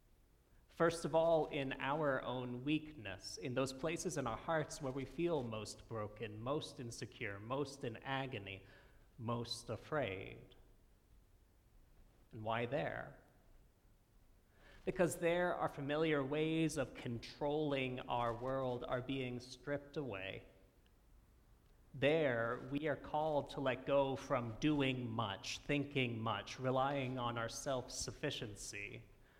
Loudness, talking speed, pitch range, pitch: -40 LUFS, 120 wpm, 110-145 Hz, 125 Hz